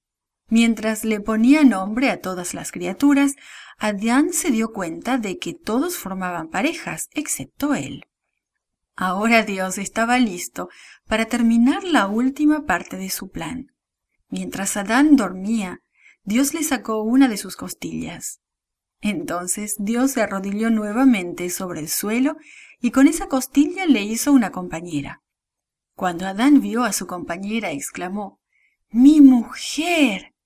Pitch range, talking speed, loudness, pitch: 195-270 Hz, 130 wpm, -20 LUFS, 225 Hz